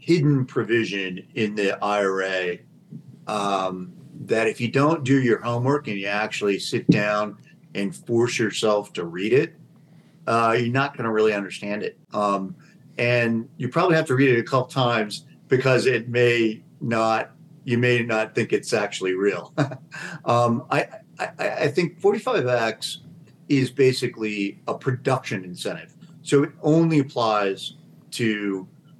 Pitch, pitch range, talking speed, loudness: 120 Hz, 105-135 Hz, 145 wpm, -23 LUFS